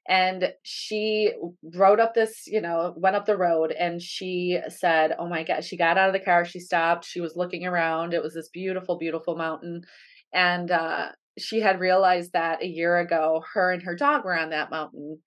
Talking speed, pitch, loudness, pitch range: 205 wpm, 175 Hz, -24 LUFS, 165-185 Hz